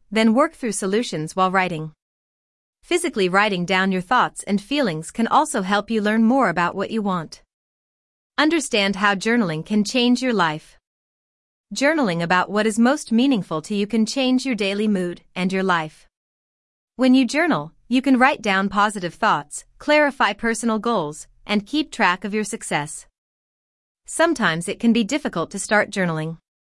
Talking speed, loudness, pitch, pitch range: 160 wpm, -20 LUFS, 210 Hz, 185-250 Hz